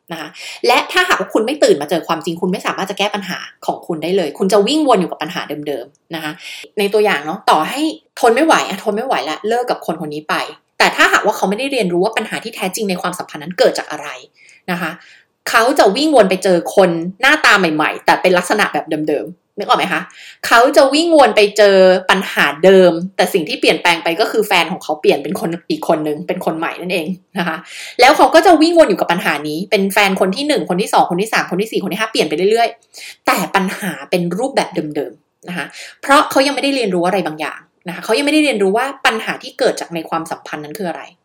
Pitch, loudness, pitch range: 195 Hz, -14 LUFS, 170-235 Hz